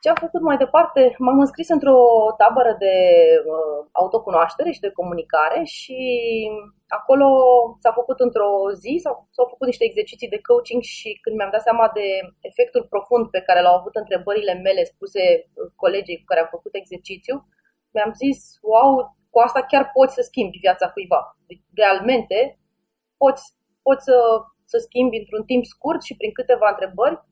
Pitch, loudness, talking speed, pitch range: 245 Hz, -18 LUFS, 155 wpm, 205-275 Hz